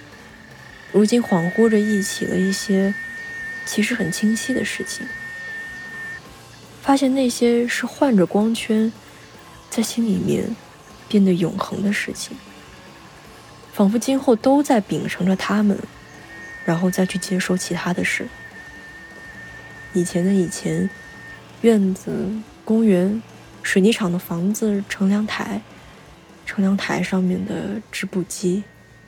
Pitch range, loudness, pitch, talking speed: 185-230 Hz, -21 LUFS, 205 Hz, 175 characters per minute